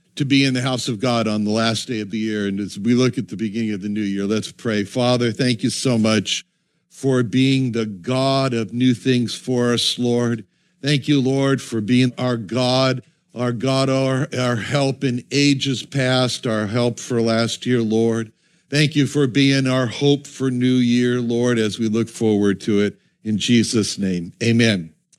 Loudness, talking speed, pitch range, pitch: -19 LUFS, 200 wpm, 110-130 Hz, 125 Hz